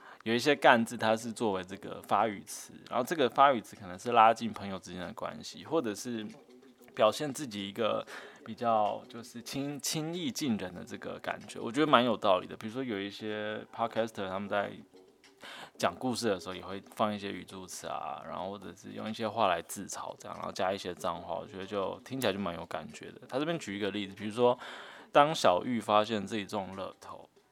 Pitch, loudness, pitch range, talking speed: 110 Hz, -32 LUFS, 100-120 Hz, 330 characters per minute